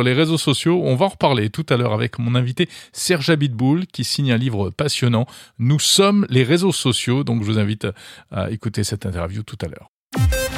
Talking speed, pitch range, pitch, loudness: 205 wpm, 110-150 Hz, 125 Hz, -19 LUFS